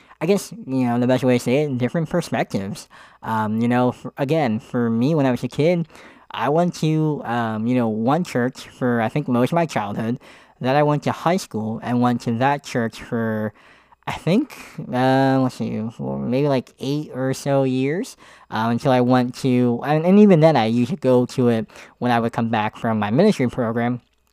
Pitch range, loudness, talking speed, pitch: 115-145 Hz, -20 LUFS, 215 wpm, 125 Hz